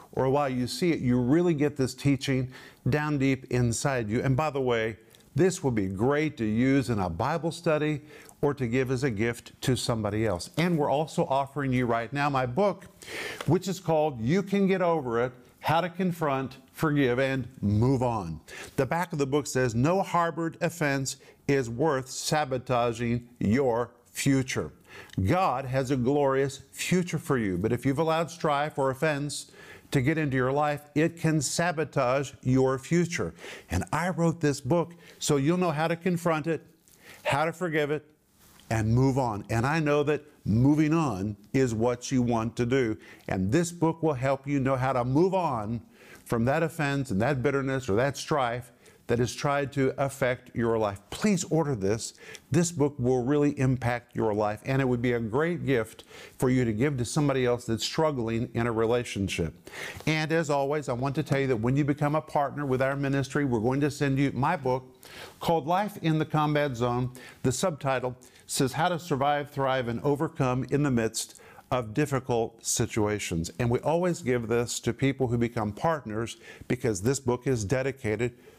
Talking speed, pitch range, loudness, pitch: 190 wpm, 120-150 Hz, -28 LUFS, 135 Hz